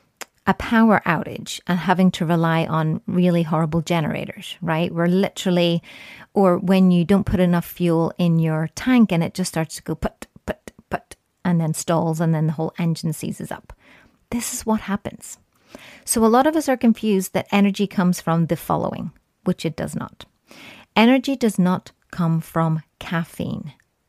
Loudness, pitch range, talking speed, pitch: -20 LUFS, 165-200 Hz, 175 wpm, 175 Hz